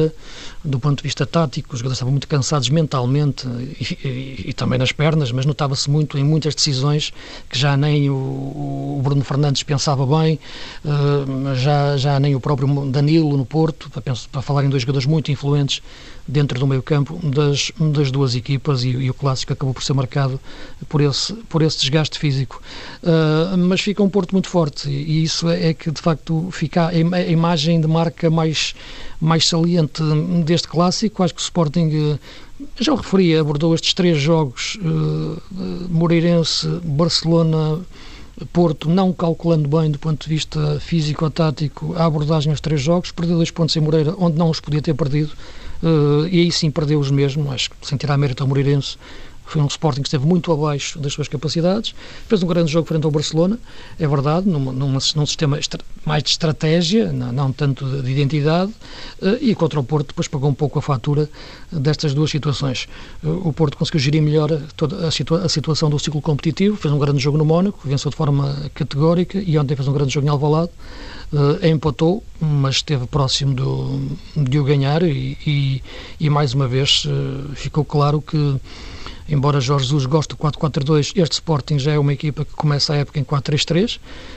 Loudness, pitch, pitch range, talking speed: -19 LUFS, 150 Hz, 140-165 Hz, 190 wpm